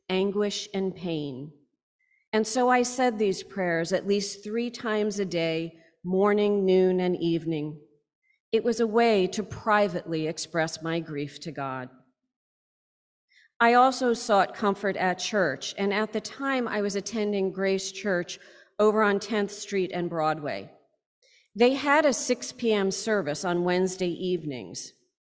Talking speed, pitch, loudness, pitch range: 140 wpm, 195 Hz, -26 LUFS, 170-220 Hz